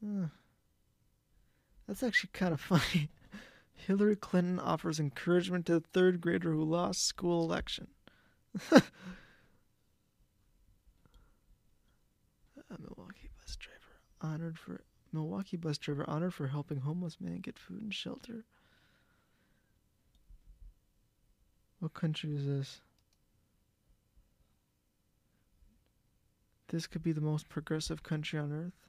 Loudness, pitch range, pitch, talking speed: -34 LUFS, 145-180 Hz, 160 Hz, 100 wpm